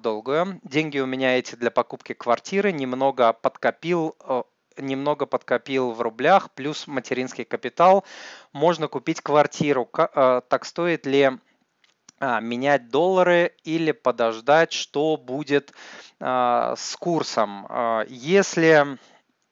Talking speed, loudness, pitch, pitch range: 100 wpm, -22 LUFS, 140 Hz, 125-160 Hz